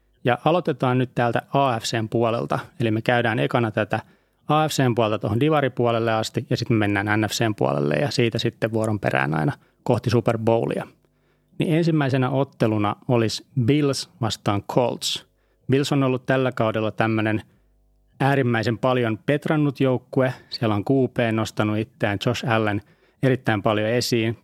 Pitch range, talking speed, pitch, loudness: 110-130 Hz, 140 wpm, 120 Hz, -22 LUFS